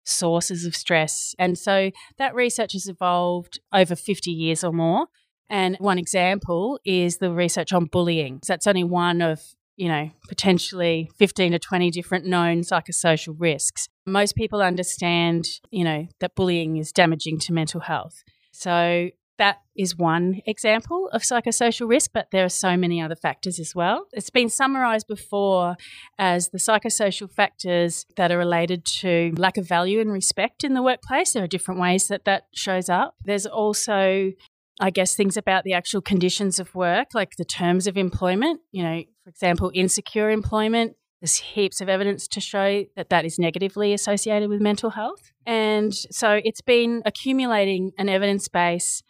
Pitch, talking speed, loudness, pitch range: 185 Hz, 170 wpm, -22 LUFS, 175-205 Hz